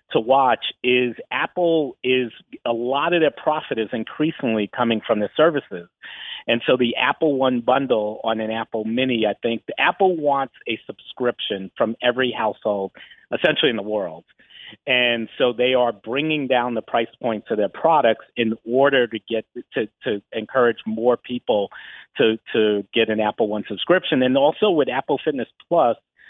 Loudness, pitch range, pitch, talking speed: -21 LUFS, 110-130 Hz, 120 Hz, 170 wpm